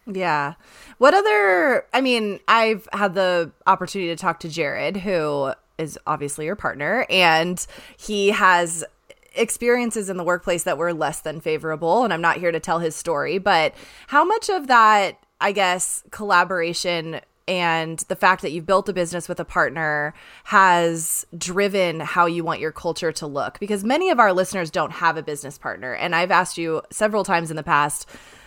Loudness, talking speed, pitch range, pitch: -20 LUFS, 180 wpm, 165-200 Hz, 175 Hz